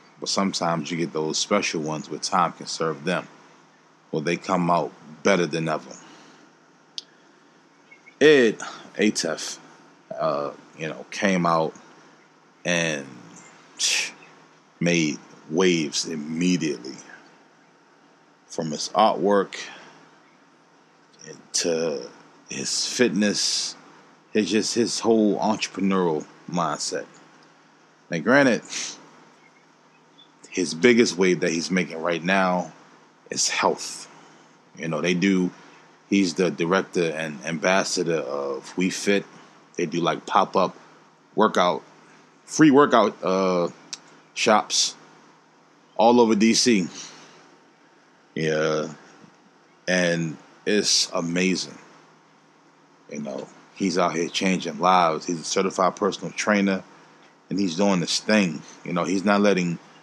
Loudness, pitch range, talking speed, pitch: -23 LUFS, 85-95 Hz, 105 wpm, 90 Hz